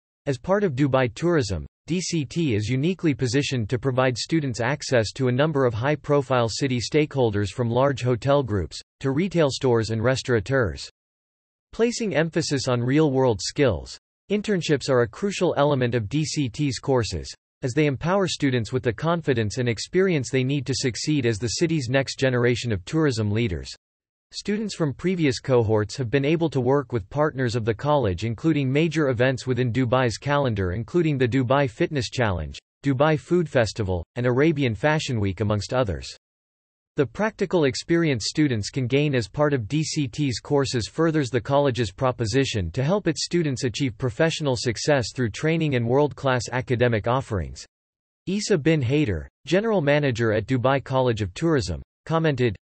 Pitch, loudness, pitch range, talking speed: 130 Hz, -23 LUFS, 120-150 Hz, 160 wpm